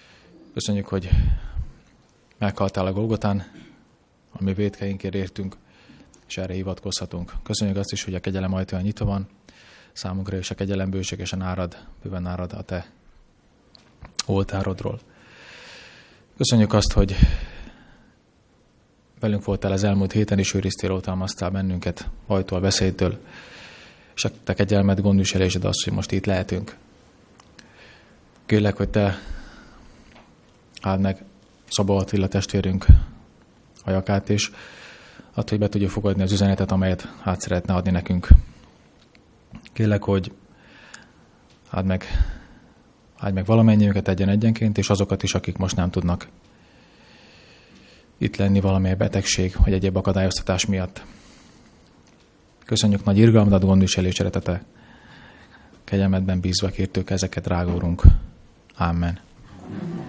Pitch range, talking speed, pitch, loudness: 90-100 Hz, 115 wpm, 95 Hz, -22 LUFS